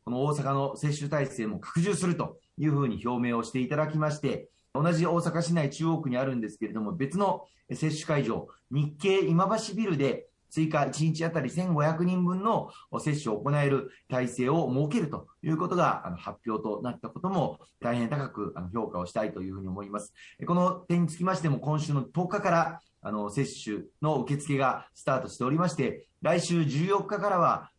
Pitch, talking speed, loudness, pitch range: 150 Hz, 365 characters per minute, -29 LUFS, 125-170 Hz